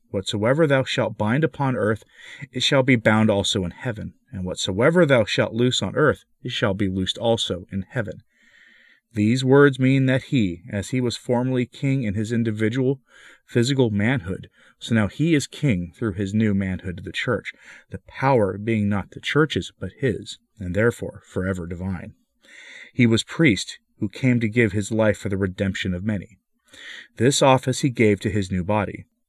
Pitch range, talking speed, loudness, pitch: 100-130 Hz, 180 wpm, -22 LUFS, 110 Hz